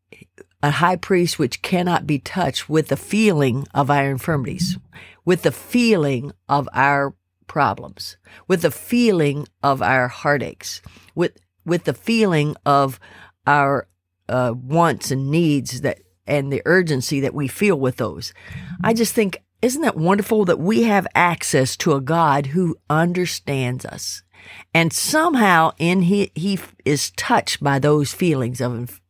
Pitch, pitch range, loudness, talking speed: 145 Hz, 130-175 Hz, -19 LUFS, 145 wpm